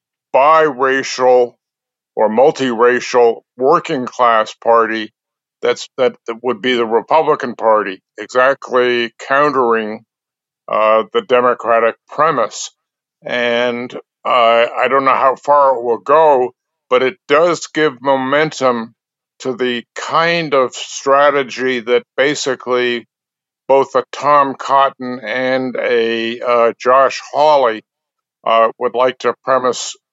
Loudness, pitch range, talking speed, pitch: -14 LUFS, 120-135 Hz, 110 wpm, 125 Hz